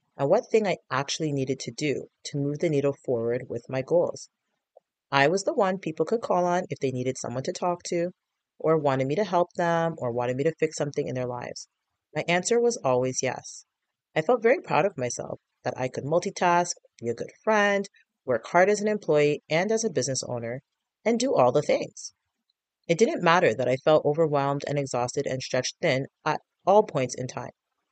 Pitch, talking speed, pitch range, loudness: 150 Hz, 210 wpm, 130-180 Hz, -26 LUFS